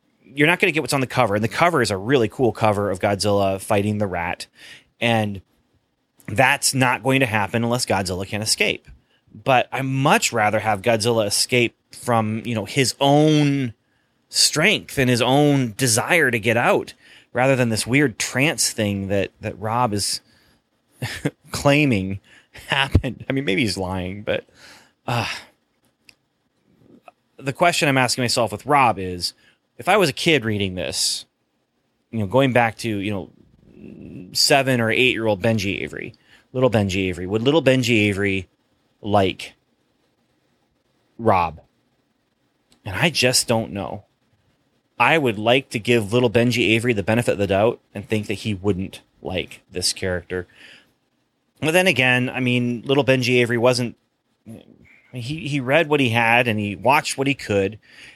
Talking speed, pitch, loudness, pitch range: 160 wpm, 115 Hz, -20 LUFS, 105-130 Hz